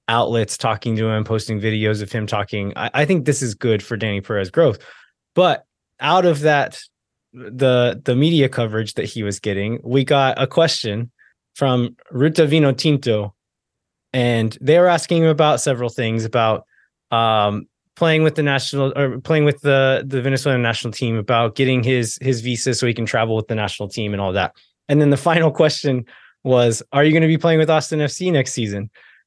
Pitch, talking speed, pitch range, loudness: 125 Hz, 195 wpm, 110-145 Hz, -18 LUFS